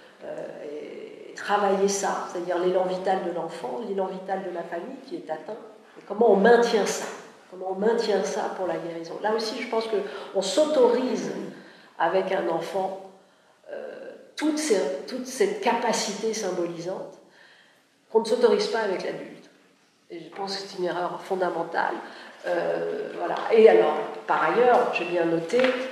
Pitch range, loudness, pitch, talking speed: 185-245 Hz, -25 LUFS, 200 Hz, 155 wpm